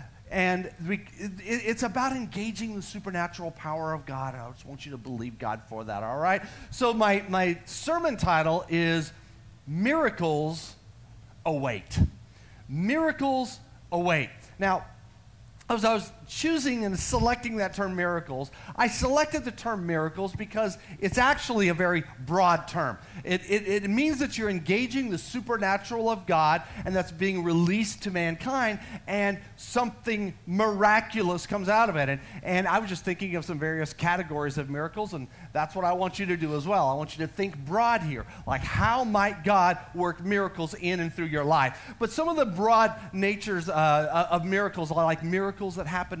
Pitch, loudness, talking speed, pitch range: 180 Hz, -27 LUFS, 170 wpm, 155-210 Hz